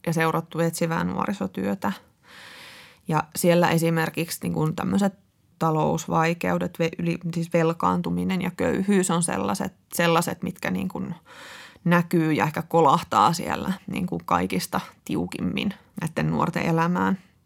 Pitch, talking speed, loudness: 165 Hz, 115 wpm, -24 LUFS